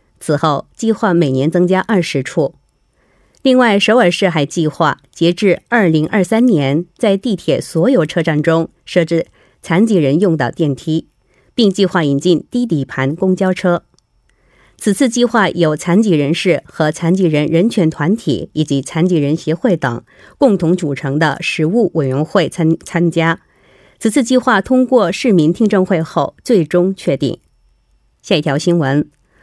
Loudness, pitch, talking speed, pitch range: -14 LUFS, 170 Hz, 230 characters per minute, 150-195 Hz